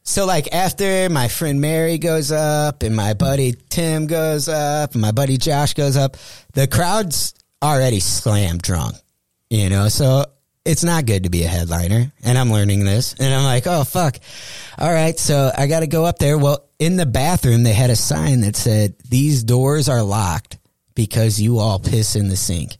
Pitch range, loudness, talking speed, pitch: 110-155 Hz, -17 LUFS, 195 wpm, 135 Hz